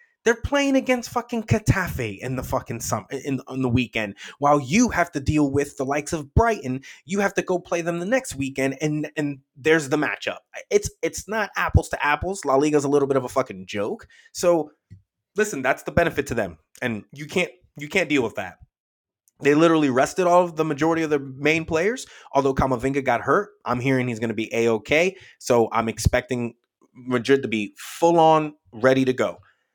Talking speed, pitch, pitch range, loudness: 205 wpm, 145 Hz, 125-170 Hz, -23 LUFS